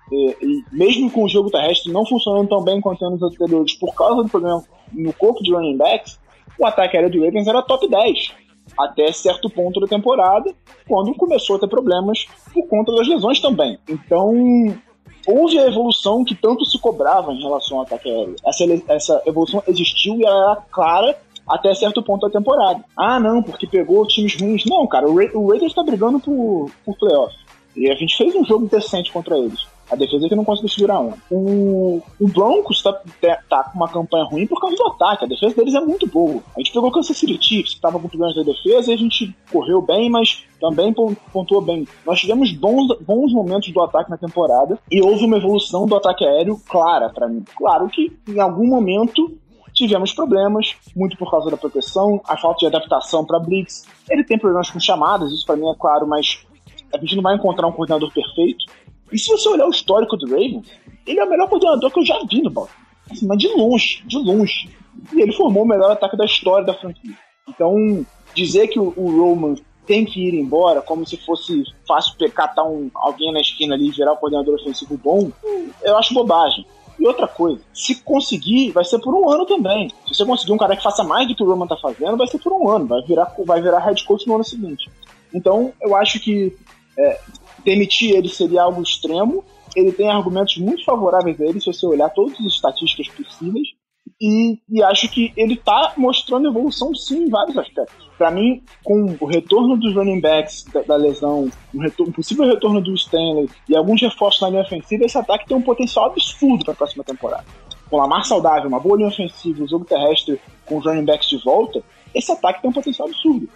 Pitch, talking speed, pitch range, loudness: 205 Hz, 210 wpm, 170-240 Hz, -17 LUFS